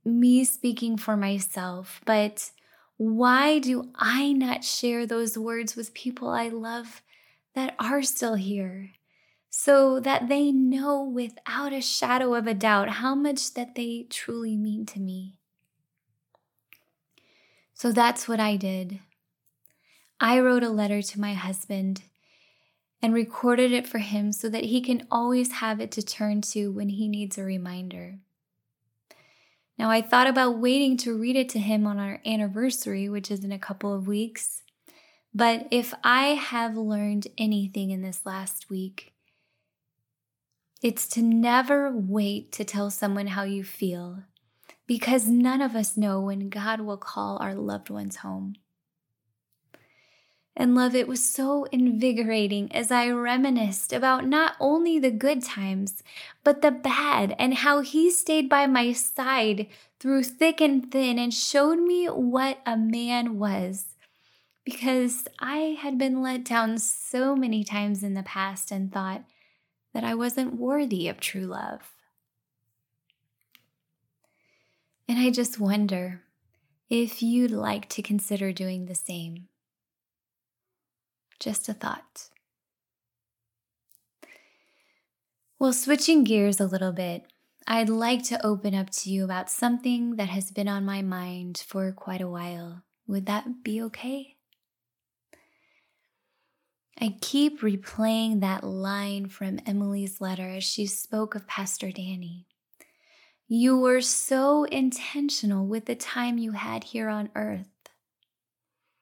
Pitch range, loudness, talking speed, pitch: 195-250 Hz, -26 LUFS, 140 wpm, 220 Hz